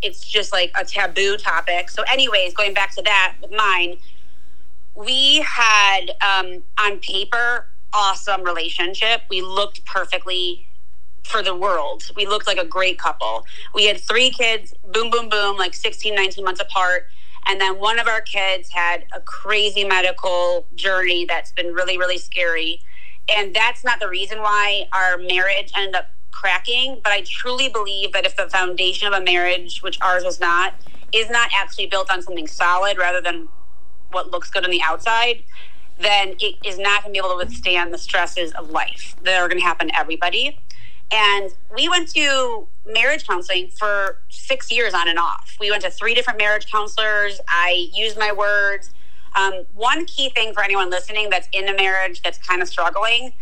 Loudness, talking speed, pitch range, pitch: -18 LUFS, 180 wpm, 180-215 Hz, 195 Hz